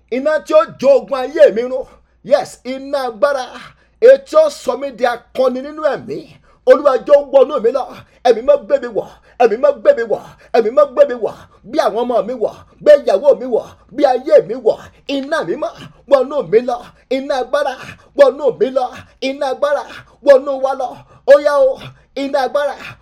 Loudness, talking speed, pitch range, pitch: -15 LUFS, 160 wpm, 255-300 Hz, 280 Hz